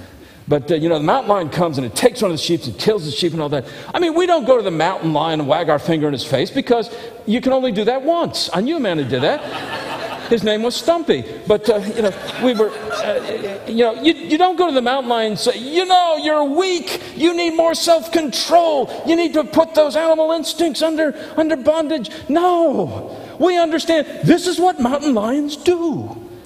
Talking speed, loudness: 225 wpm, -17 LUFS